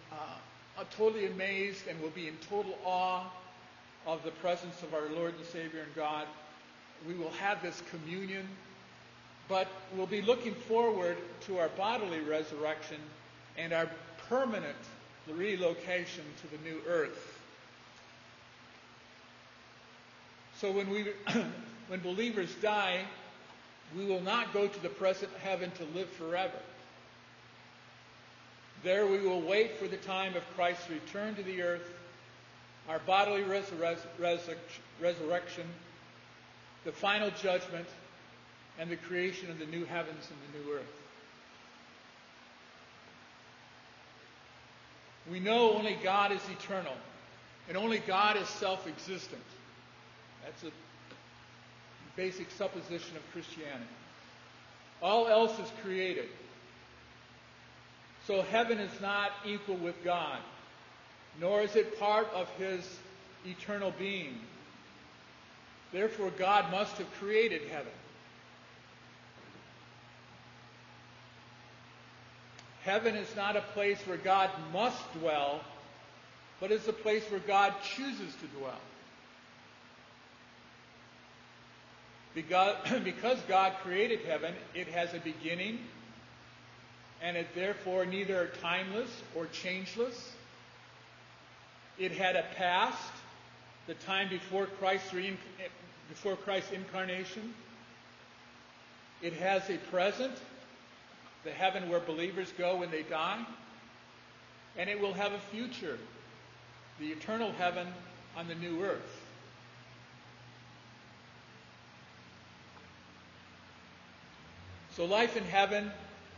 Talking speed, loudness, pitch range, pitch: 110 wpm, -35 LUFS, 165-200 Hz, 185 Hz